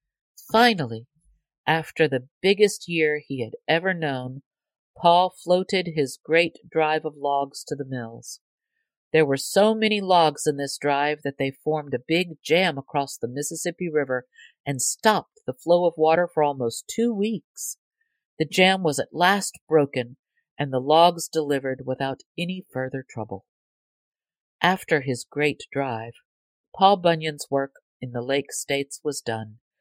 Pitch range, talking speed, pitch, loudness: 135-175 Hz, 150 wpm, 150 Hz, -23 LUFS